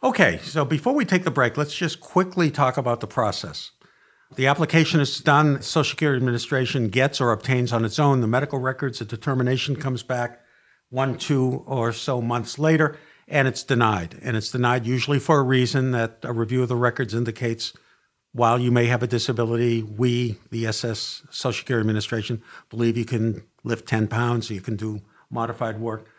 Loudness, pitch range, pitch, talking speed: -23 LUFS, 115-140 Hz, 125 Hz, 185 wpm